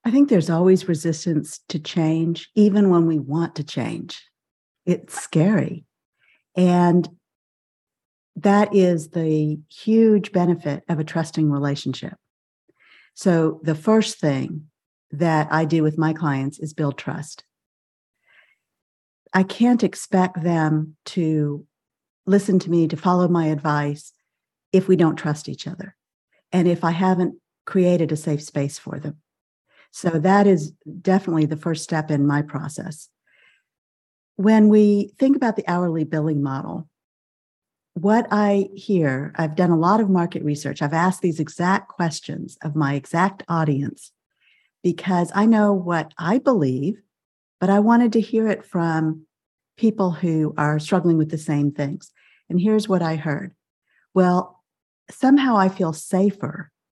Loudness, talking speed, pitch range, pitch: -20 LUFS, 140 wpm, 155-190 Hz, 170 Hz